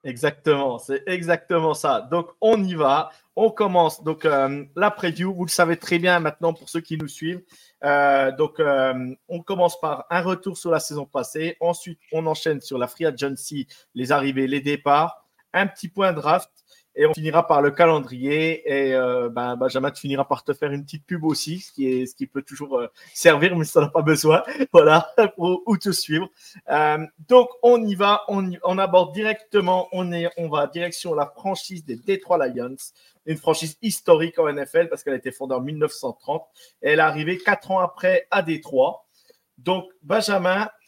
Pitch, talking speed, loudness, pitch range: 165 Hz, 190 wpm, -21 LUFS, 145-185 Hz